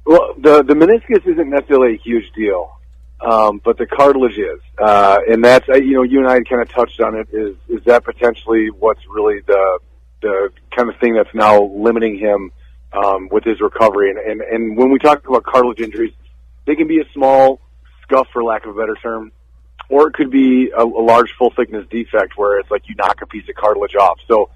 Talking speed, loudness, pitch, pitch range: 215 wpm, -14 LUFS, 115 Hz, 105-135 Hz